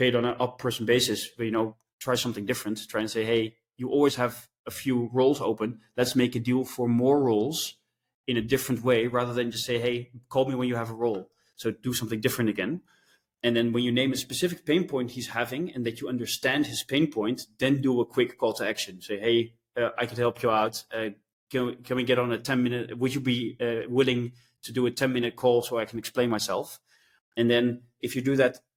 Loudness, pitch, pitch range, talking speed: -27 LUFS, 120 Hz, 115-125 Hz, 230 wpm